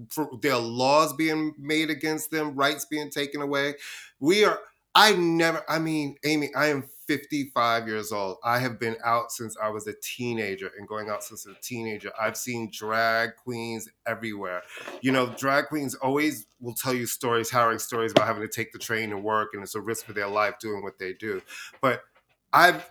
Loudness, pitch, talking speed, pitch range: -26 LUFS, 120 Hz, 195 wpm, 110-145 Hz